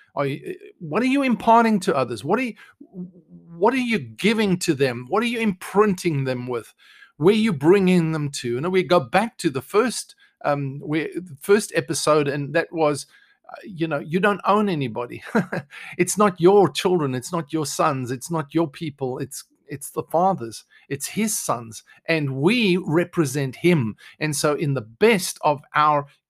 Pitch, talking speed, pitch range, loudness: 170 Hz, 185 wpm, 145-205 Hz, -22 LUFS